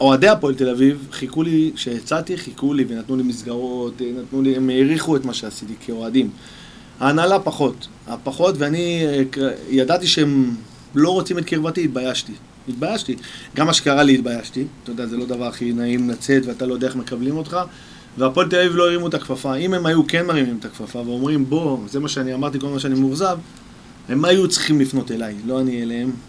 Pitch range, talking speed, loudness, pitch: 125-155 Hz, 185 wpm, -19 LUFS, 135 Hz